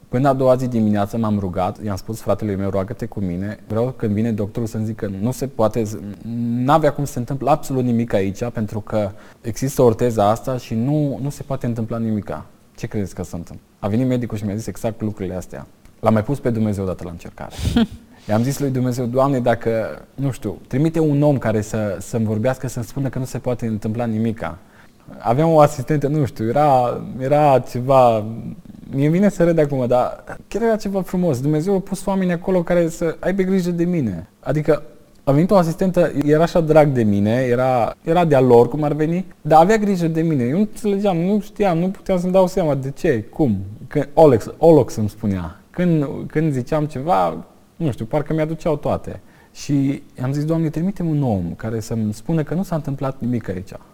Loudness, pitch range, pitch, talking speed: -19 LUFS, 110-155 Hz, 130 Hz, 205 wpm